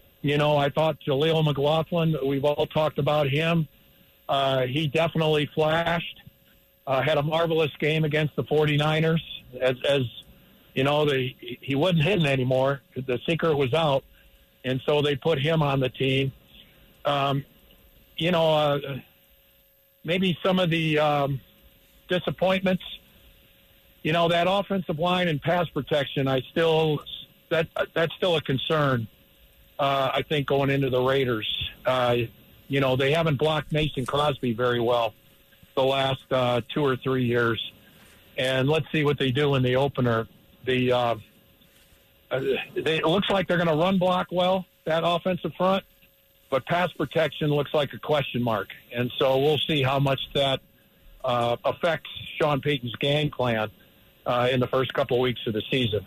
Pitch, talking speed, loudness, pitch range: 145 Hz, 160 wpm, -25 LUFS, 130-160 Hz